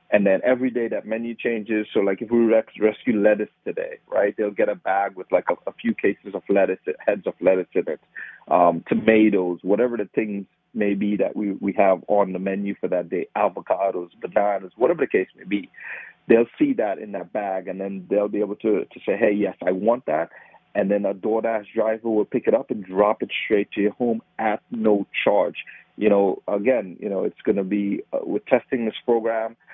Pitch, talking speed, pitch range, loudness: 105 Hz, 220 wpm, 100-115 Hz, -22 LUFS